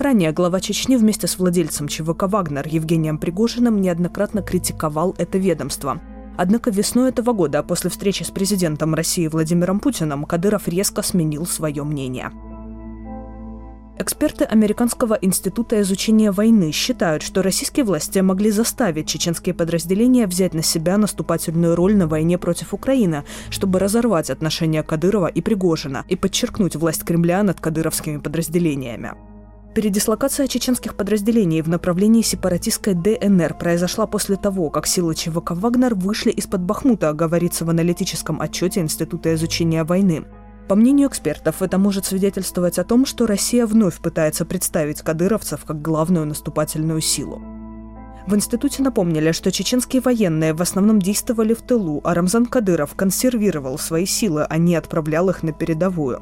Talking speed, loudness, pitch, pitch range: 140 wpm, -19 LUFS, 180 Hz, 160-210 Hz